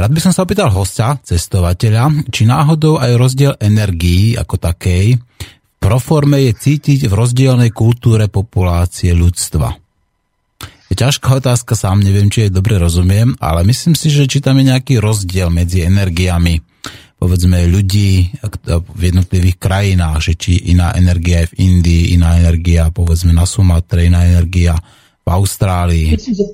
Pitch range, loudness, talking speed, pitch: 90-120 Hz, -12 LUFS, 145 wpm, 100 Hz